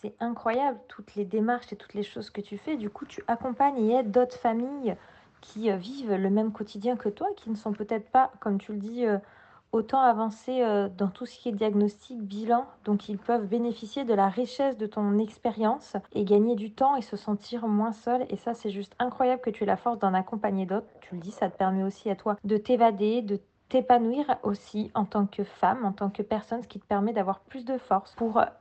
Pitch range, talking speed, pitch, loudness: 205-240 Hz, 225 wpm, 220 Hz, -28 LUFS